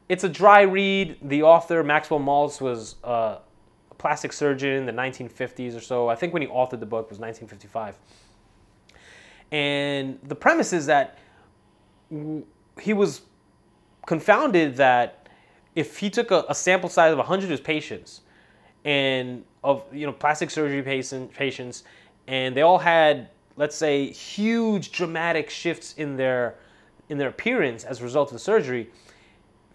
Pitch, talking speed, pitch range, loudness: 140 Hz, 150 wpm, 125-165 Hz, -23 LUFS